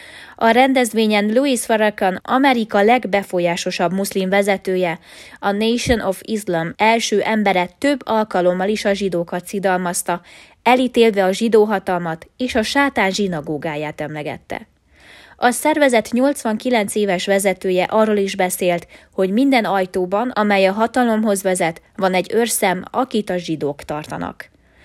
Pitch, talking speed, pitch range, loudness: 200 Hz, 120 wpm, 180-230 Hz, -18 LUFS